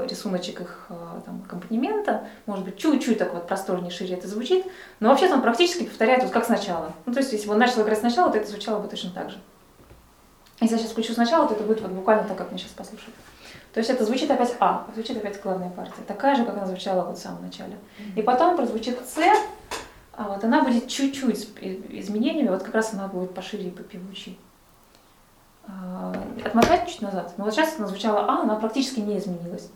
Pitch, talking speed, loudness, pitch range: 215 Hz, 200 wpm, -24 LUFS, 195-250 Hz